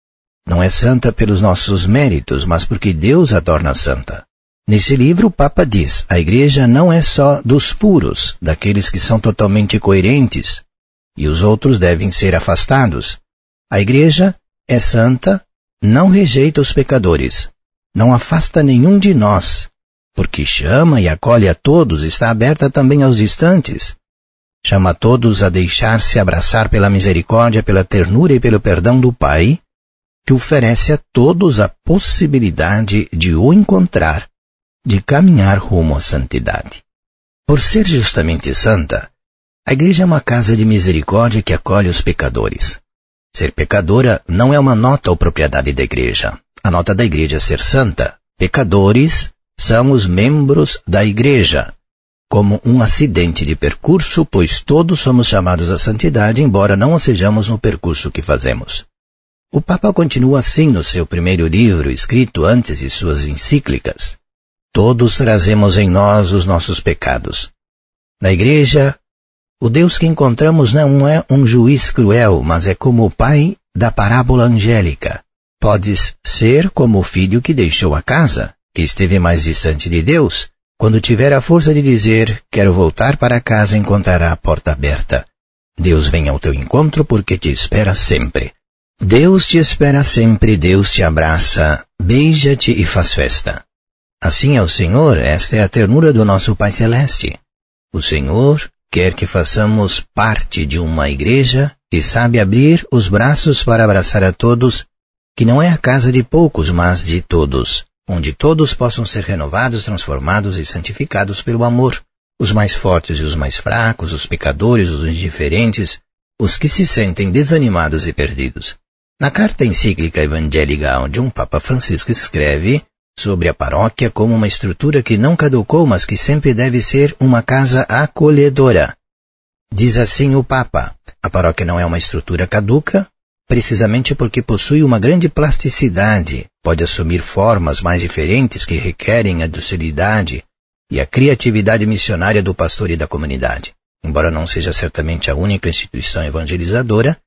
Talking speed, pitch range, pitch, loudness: 150 wpm, 85-130 Hz, 105 Hz, -12 LUFS